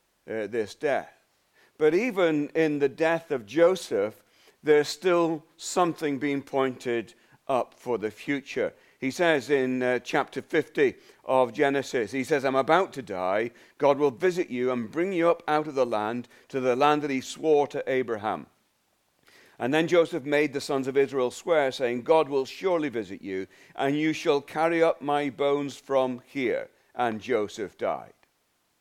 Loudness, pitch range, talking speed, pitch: -26 LUFS, 130-165 Hz, 165 wpm, 145 Hz